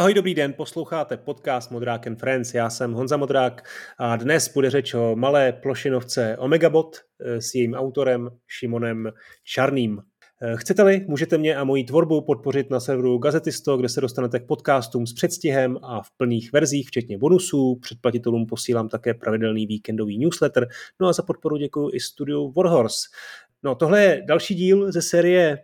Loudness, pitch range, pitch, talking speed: -22 LUFS, 120-155 Hz, 135 Hz, 160 wpm